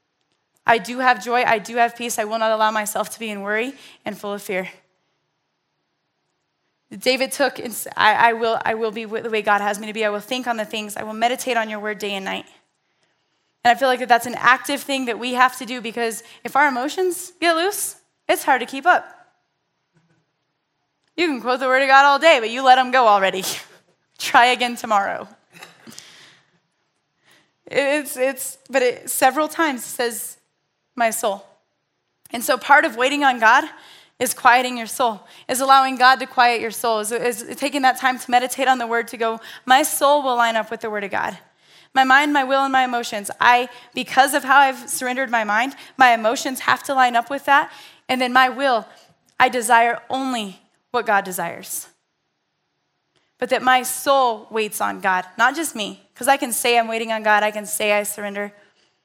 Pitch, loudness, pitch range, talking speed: 245 Hz, -19 LUFS, 220-265 Hz, 205 wpm